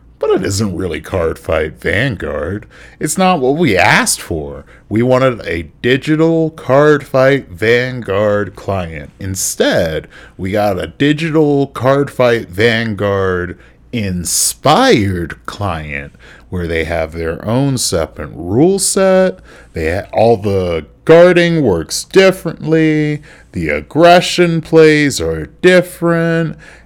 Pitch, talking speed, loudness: 120 Hz, 115 wpm, -13 LUFS